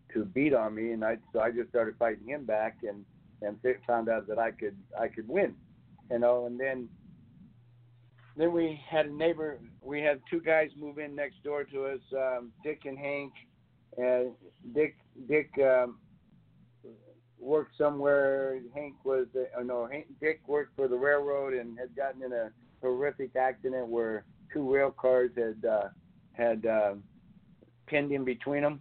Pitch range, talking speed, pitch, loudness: 120-145 Hz, 170 wpm, 130 Hz, -31 LUFS